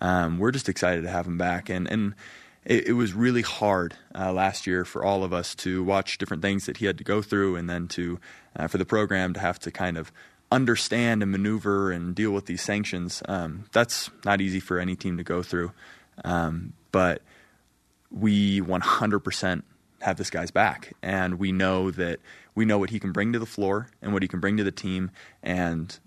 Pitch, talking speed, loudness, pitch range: 95 Hz, 225 wpm, -26 LUFS, 90-100 Hz